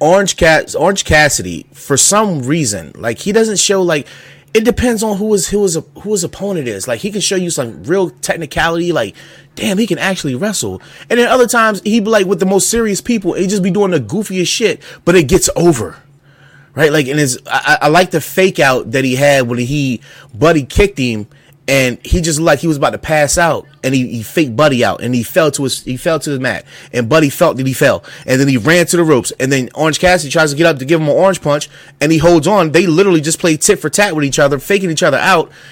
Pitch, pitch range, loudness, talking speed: 160 Hz, 140-190 Hz, -12 LUFS, 245 wpm